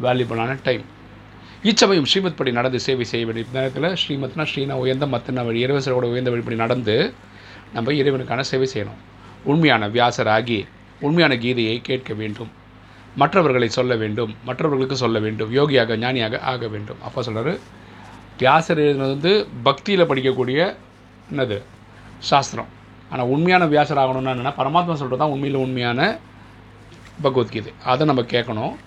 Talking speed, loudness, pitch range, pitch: 125 wpm, -20 LUFS, 115-135 Hz, 125 Hz